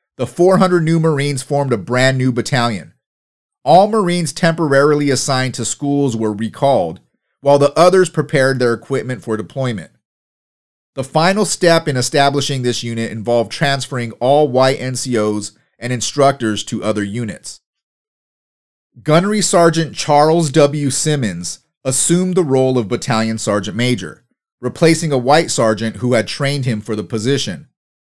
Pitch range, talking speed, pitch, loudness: 120-155 Hz, 140 wpm, 135 Hz, -15 LUFS